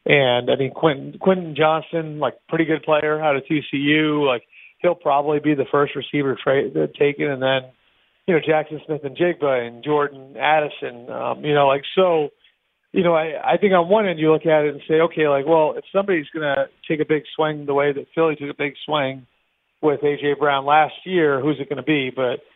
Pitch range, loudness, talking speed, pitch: 140-160 Hz, -20 LUFS, 210 wpm, 150 Hz